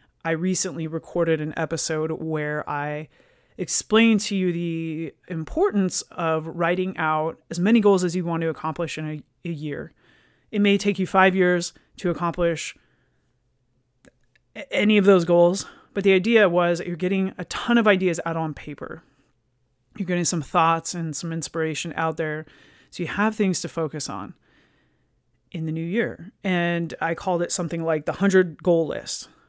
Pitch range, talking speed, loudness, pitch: 160-185 Hz, 170 wpm, -23 LUFS, 170 Hz